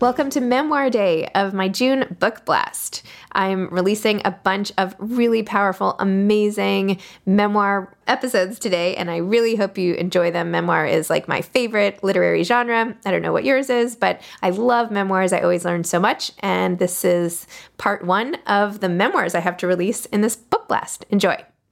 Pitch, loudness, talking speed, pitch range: 200 Hz, -20 LUFS, 180 wpm, 185-230 Hz